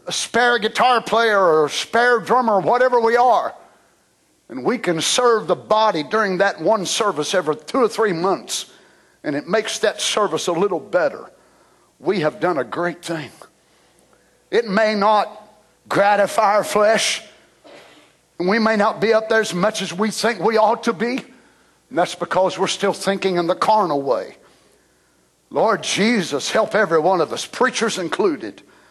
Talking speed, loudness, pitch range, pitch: 170 wpm, -18 LUFS, 180-230 Hz, 210 Hz